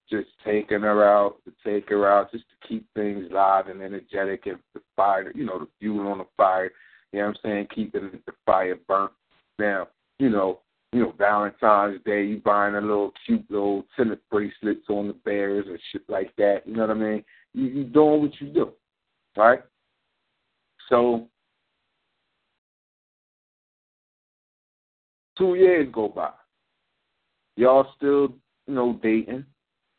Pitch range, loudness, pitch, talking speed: 100-120 Hz, -23 LUFS, 105 Hz, 155 wpm